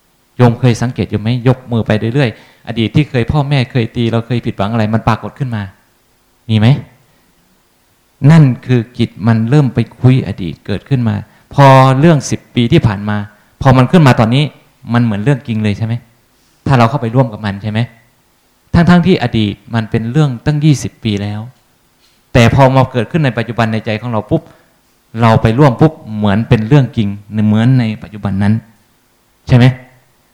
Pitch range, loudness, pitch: 110-130 Hz, -12 LUFS, 120 Hz